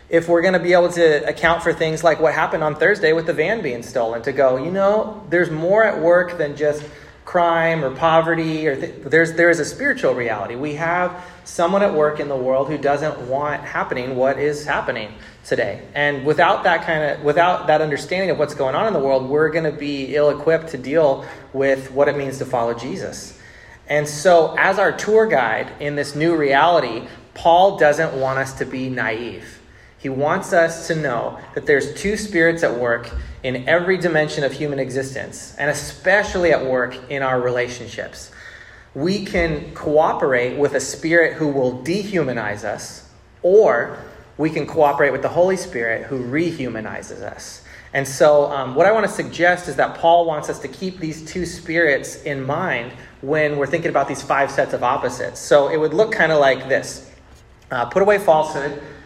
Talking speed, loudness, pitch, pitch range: 190 wpm, -18 LUFS, 150 Hz, 135-170 Hz